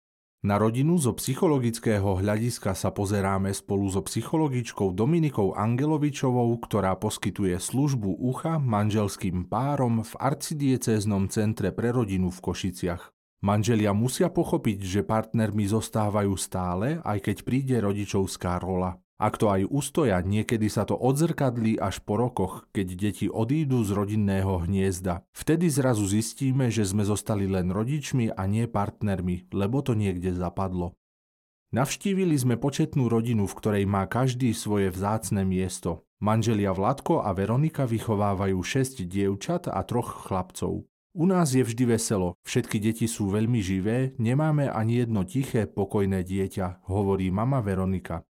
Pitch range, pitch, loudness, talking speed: 95-125 Hz, 105 Hz, -26 LUFS, 135 wpm